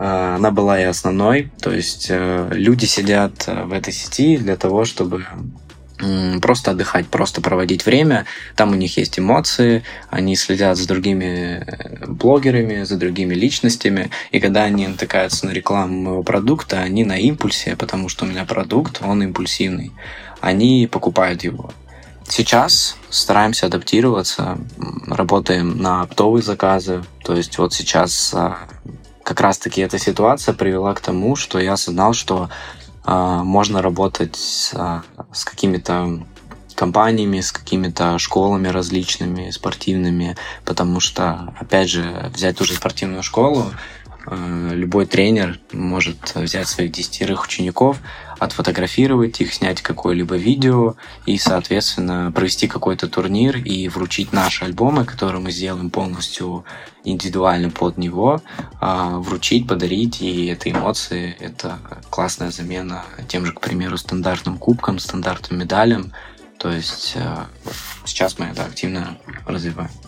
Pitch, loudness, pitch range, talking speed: 95 Hz, -18 LUFS, 90-100 Hz, 125 wpm